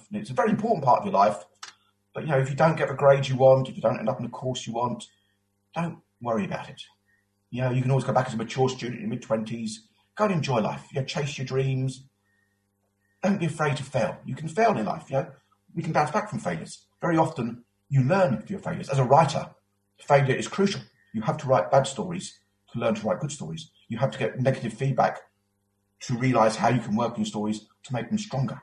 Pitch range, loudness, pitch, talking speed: 110-150 Hz, -26 LUFS, 130 Hz, 245 wpm